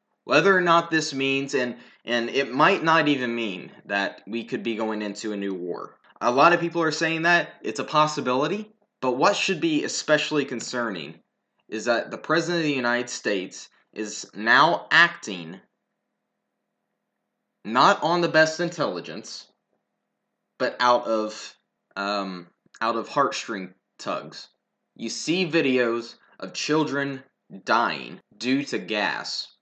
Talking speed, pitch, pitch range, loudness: 140 wpm, 135 Hz, 115-160 Hz, -23 LUFS